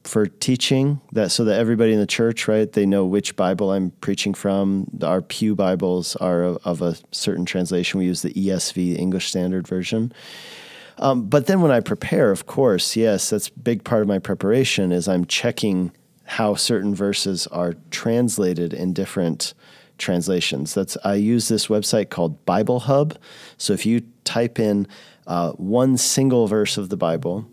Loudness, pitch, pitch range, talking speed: -21 LUFS, 100 Hz, 90-115 Hz, 175 wpm